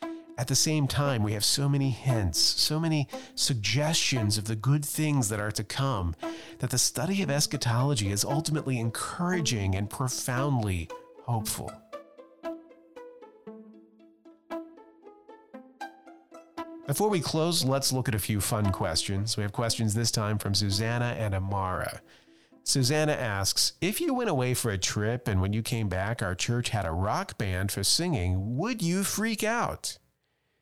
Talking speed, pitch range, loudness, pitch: 150 wpm, 110-175 Hz, -28 LUFS, 130 Hz